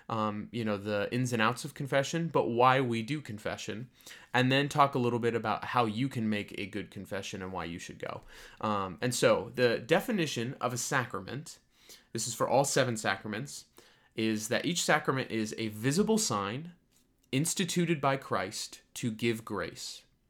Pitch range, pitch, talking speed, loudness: 110-140 Hz, 120 Hz, 180 wpm, -31 LUFS